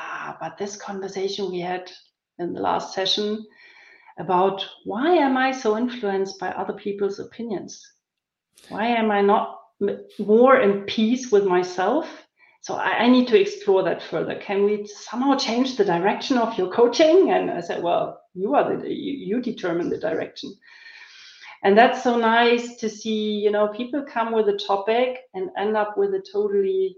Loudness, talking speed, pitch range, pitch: -22 LUFS, 170 wpm, 200-275 Hz, 225 Hz